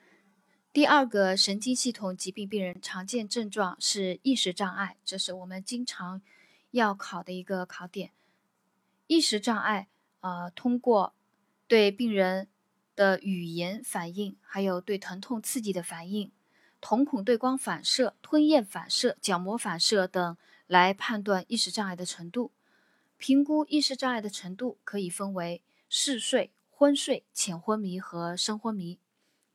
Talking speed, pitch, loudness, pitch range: 220 characters per minute, 200 Hz, -28 LUFS, 185-245 Hz